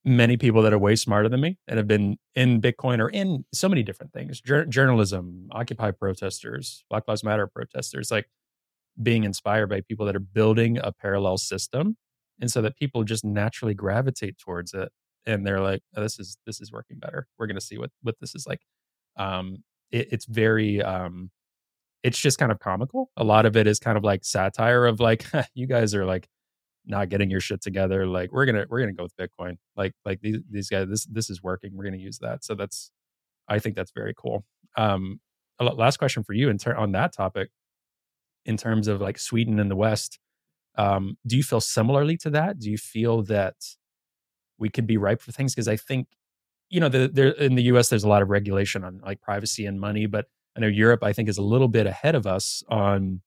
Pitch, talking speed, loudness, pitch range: 110 Hz, 215 wpm, -24 LUFS, 100-120 Hz